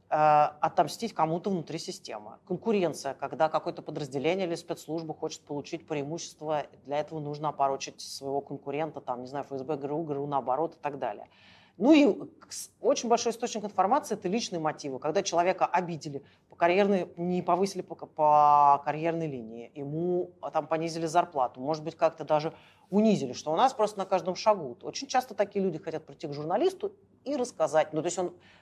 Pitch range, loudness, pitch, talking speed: 145-185 Hz, -29 LUFS, 160 Hz, 170 wpm